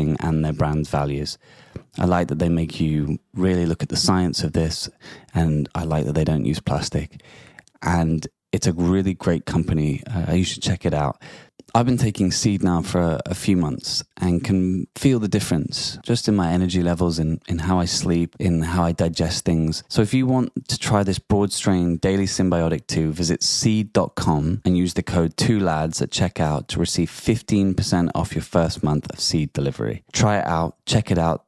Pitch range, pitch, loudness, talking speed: 80-95 Hz, 90 Hz, -21 LUFS, 200 wpm